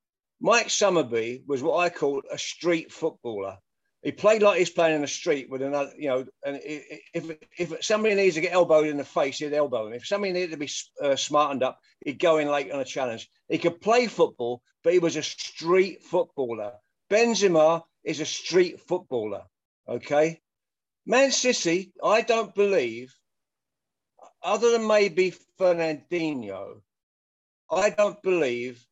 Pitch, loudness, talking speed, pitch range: 165 Hz, -25 LUFS, 160 wpm, 140-190 Hz